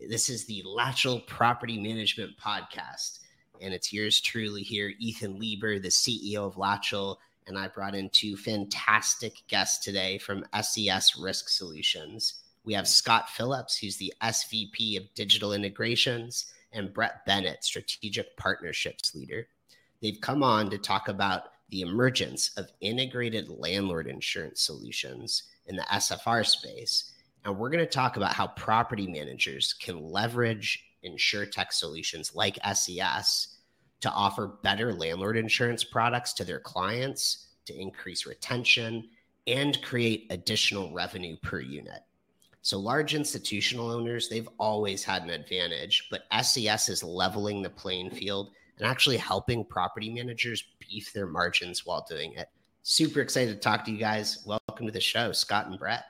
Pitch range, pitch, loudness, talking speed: 100-120 Hz, 110 Hz, -28 LUFS, 150 wpm